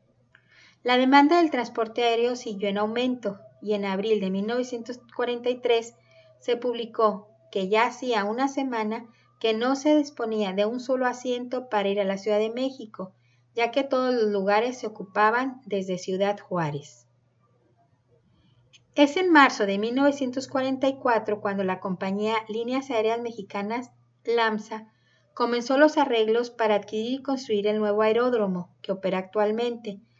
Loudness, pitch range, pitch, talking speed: -25 LUFS, 200-245 Hz, 220 Hz, 140 wpm